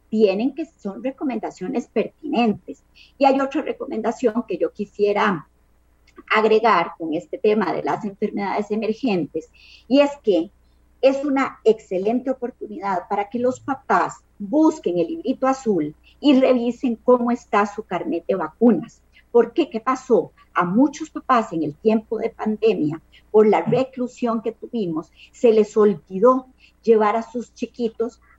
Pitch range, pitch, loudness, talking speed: 210-260 Hz, 230 Hz, -21 LUFS, 140 wpm